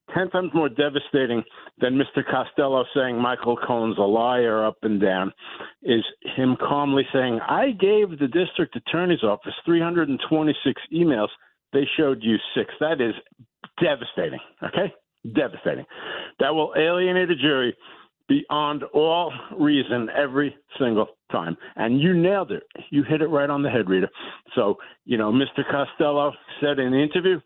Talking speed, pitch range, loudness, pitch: 150 wpm, 125-165 Hz, -23 LUFS, 145 Hz